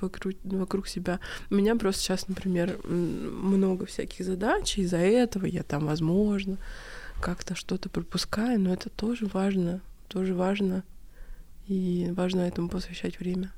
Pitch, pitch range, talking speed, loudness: 190 Hz, 180-195 Hz, 135 wpm, -29 LUFS